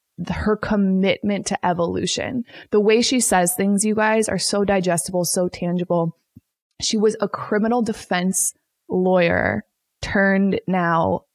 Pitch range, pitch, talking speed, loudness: 180-215 Hz, 195 Hz, 125 wpm, -20 LUFS